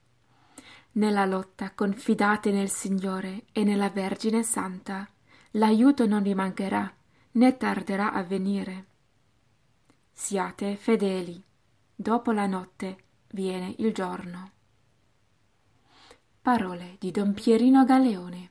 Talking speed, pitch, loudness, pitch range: 95 wpm, 195 Hz, -26 LUFS, 180-215 Hz